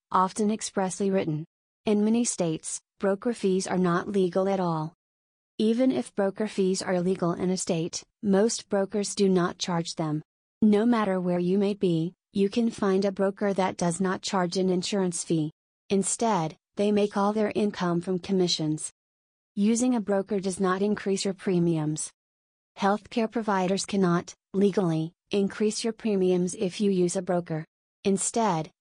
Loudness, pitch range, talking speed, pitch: -27 LUFS, 175-205 Hz, 155 wpm, 190 Hz